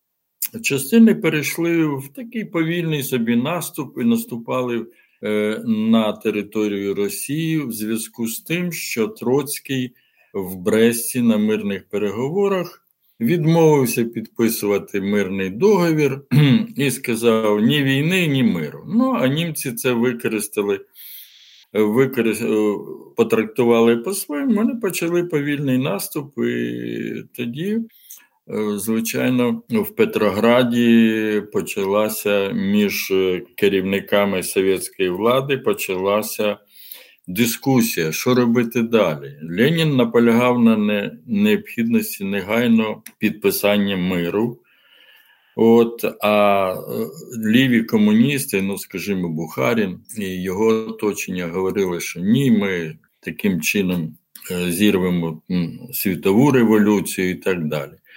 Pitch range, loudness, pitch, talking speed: 105-150 Hz, -19 LUFS, 115 Hz, 95 wpm